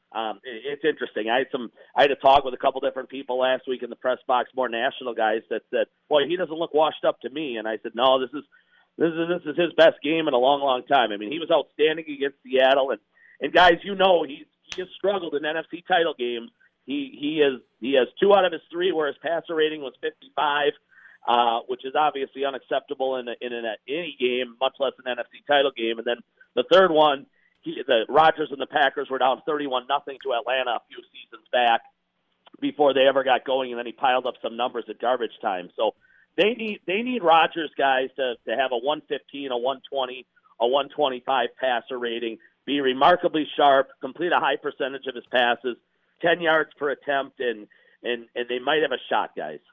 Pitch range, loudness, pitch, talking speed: 130-170 Hz, -24 LUFS, 140 Hz, 225 wpm